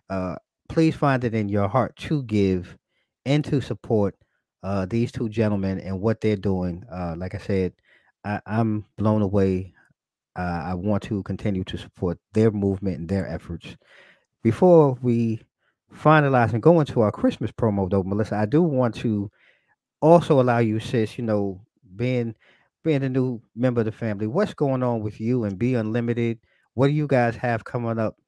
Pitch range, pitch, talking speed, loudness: 100-125 Hz, 110 Hz, 180 wpm, -23 LUFS